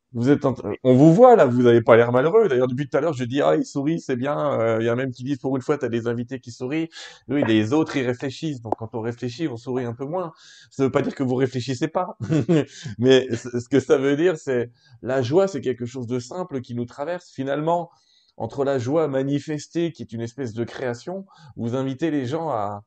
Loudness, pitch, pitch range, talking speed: -22 LUFS, 135 Hz, 125-155 Hz, 255 wpm